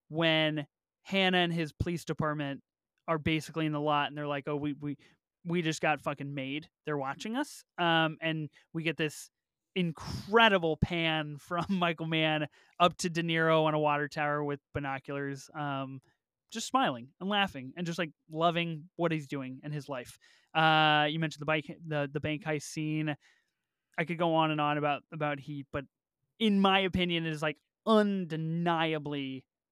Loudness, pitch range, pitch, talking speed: -31 LUFS, 145-170 Hz, 155 Hz, 175 wpm